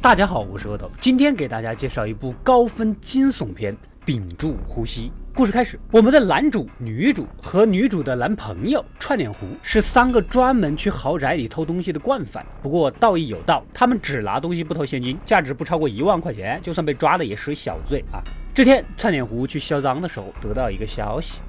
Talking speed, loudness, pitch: 315 characters per minute, -20 LUFS, 160 Hz